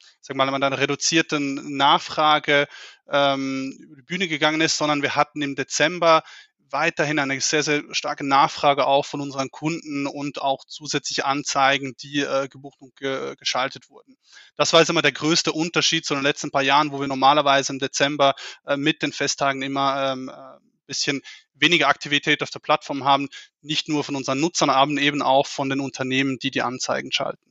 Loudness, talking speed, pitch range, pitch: -21 LUFS, 185 wpm, 135-150 Hz, 140 Hz